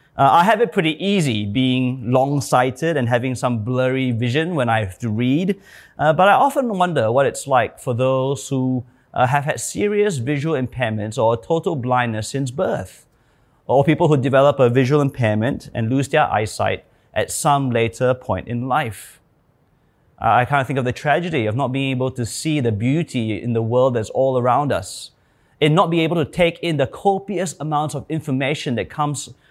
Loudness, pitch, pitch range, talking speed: -19 LUFS, 135 Hz, 125-155 Hz, 195 wpm